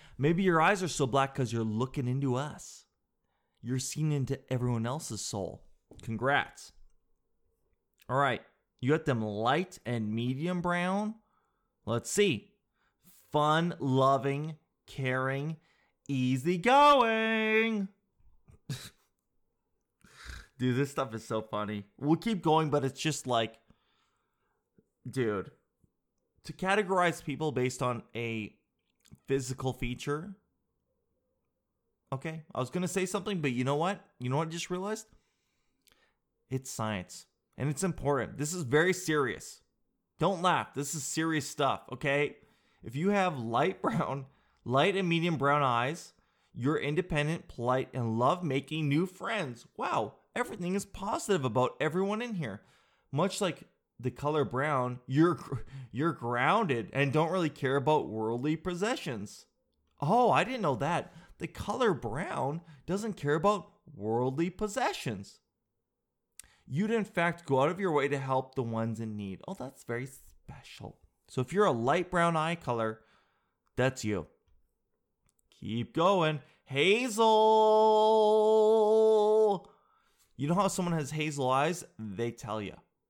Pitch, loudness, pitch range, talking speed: 145 Hz, -30 LUFS, 125-180 Hz, 130 wpm